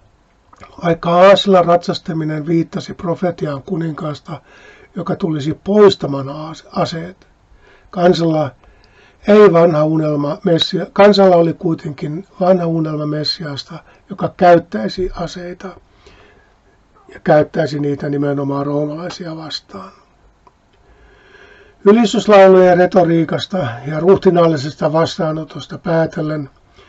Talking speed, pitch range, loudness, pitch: 80 wpm, 155-185 Hz, -14 LUFS, 165 Hz